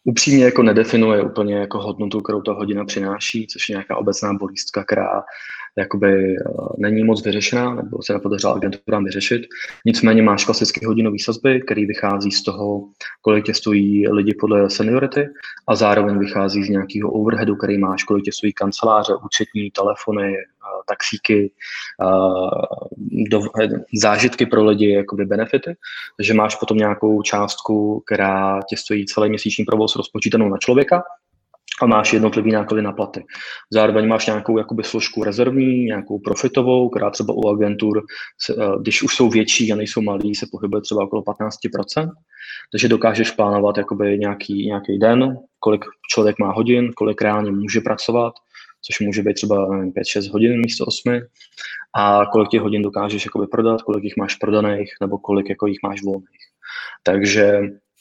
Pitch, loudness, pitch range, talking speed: 105 Hz, -18 LUFS, 100-110 Hz, 155 wpm